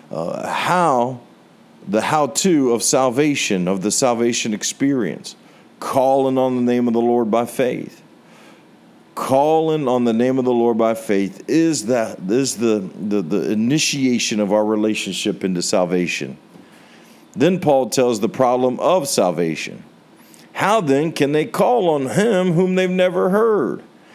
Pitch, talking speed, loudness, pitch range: 125 Hz, 145 wpm, -18 LUFS, 110-150 Hz